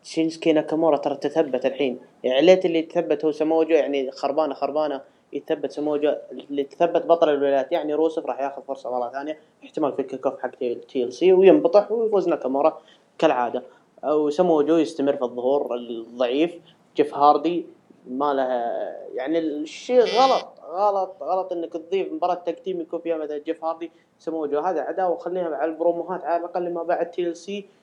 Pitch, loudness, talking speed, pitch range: 160 Hz, -23 LUFS, 160 wpm, 145-175 Hz